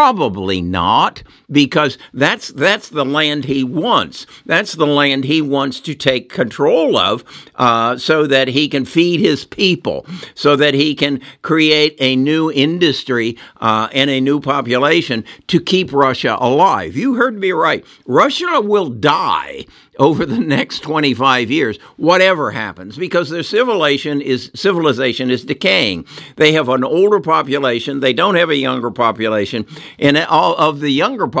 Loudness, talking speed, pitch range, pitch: -14 LUFS, 155 wpm, 130-160 Hz, 145 Hz